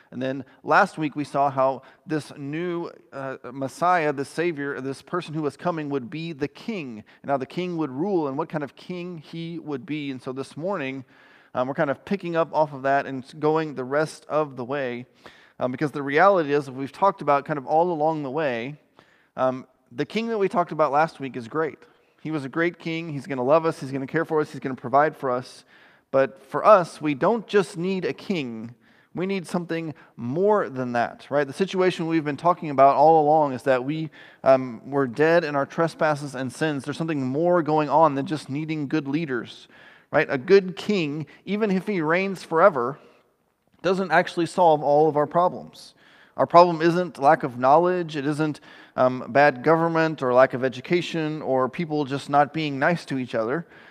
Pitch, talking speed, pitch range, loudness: 150 Hz, 210 wpm, 135-165 Hz, -23 LUFS